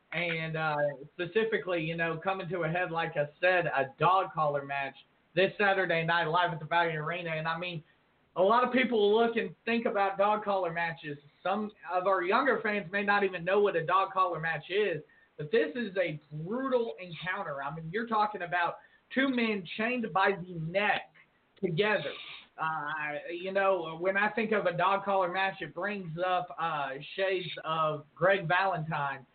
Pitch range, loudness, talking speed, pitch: 165-205 Hz, -30 LUFS, 185 wpm, 180 Hz